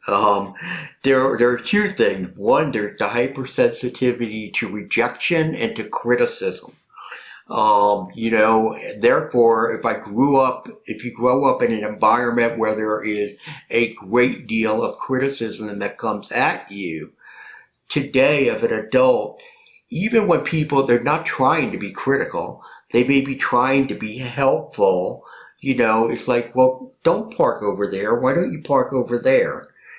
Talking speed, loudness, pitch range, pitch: 155 wpm, -20 LUFS, 110-140 Hz, 125 Hz